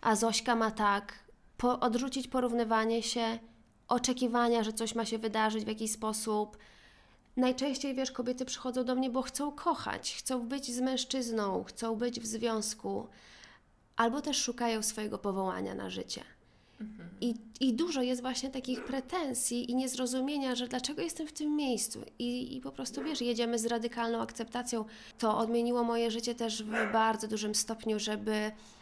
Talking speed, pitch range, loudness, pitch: 155 wpm, 225-255 Hz, -33 LUFS, 235 Hz